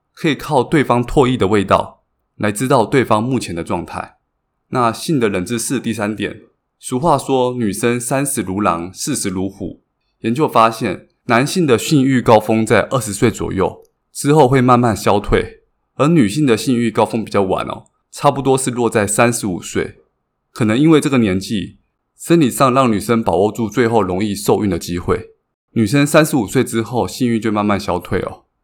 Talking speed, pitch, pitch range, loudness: 270 characters per minute, 115 Hz, 105-135 Hz, -16 LUFS